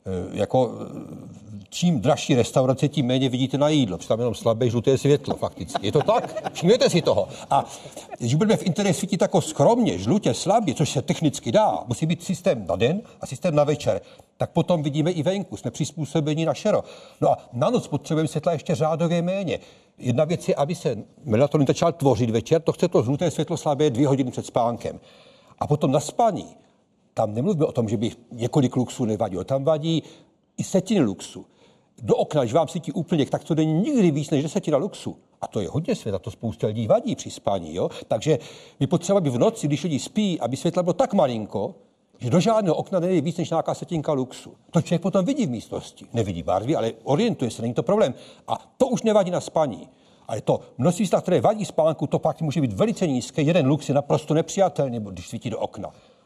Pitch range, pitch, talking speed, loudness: 130-175 Hz, 155 Hz, 205 wpm, -23 LUFS